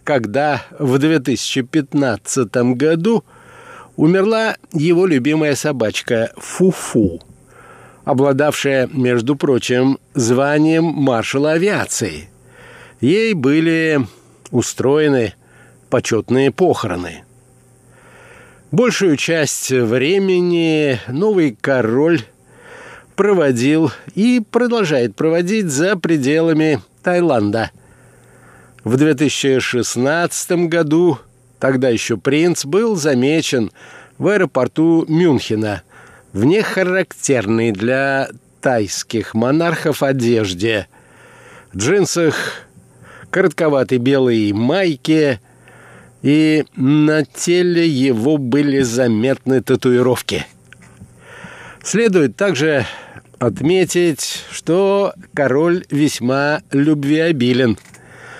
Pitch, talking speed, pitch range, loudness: 140 Hz, 70 wpm, 125-165 Hz, -16 LUFS